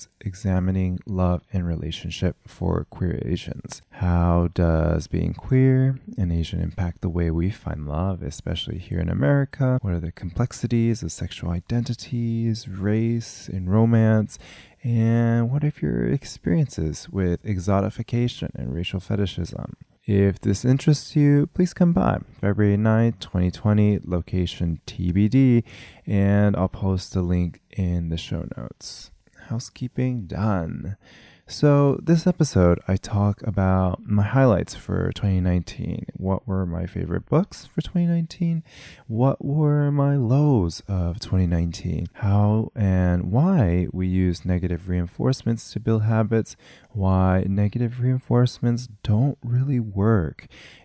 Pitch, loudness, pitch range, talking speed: 100 Hz, -23 LUFS, 90-120 Hz, 125 wpm